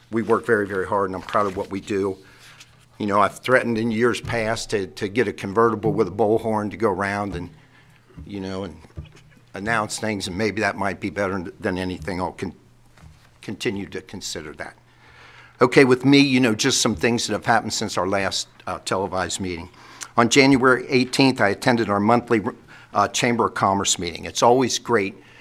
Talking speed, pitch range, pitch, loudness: 195 wpm, 100-125 Hz, 110 Hz, -21 LUFS